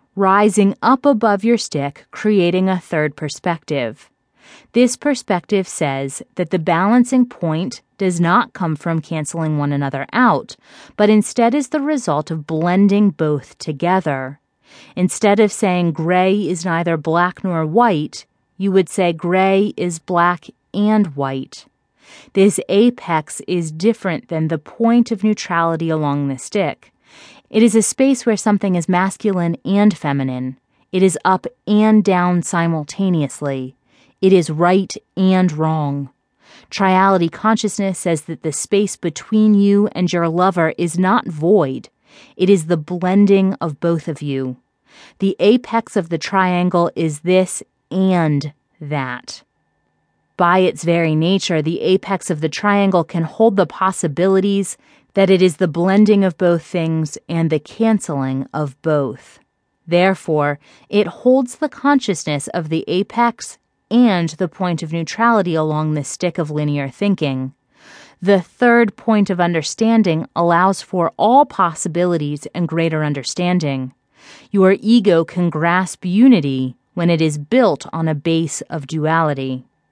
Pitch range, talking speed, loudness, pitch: 160-200 Hz, 140 wpm, -17 LUFS, 180 Hz